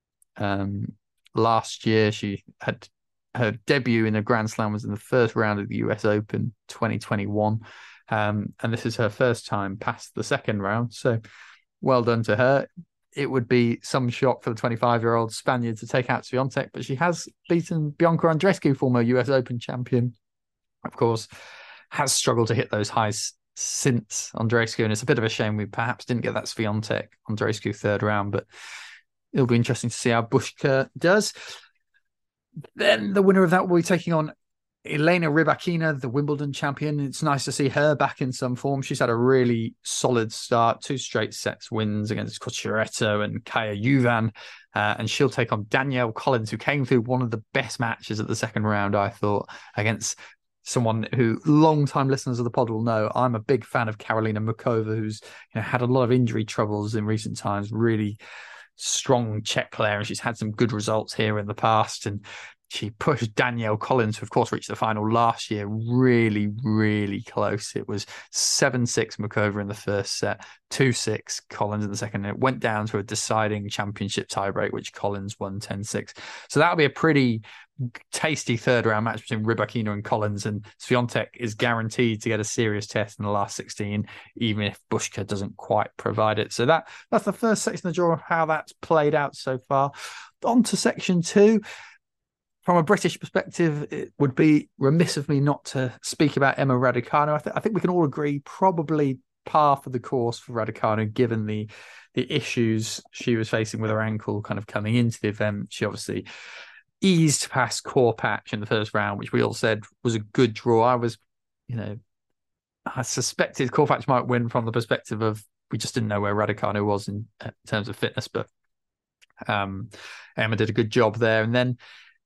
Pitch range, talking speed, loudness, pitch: 110-135 Hz, 190 wpm, -24 LUFS, 115 Hz